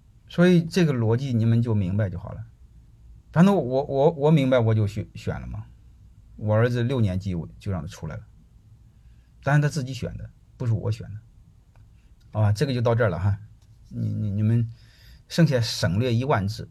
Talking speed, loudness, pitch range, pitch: 265 characters per minute, -24 LUFS, 105-125 Hz, 110 Hz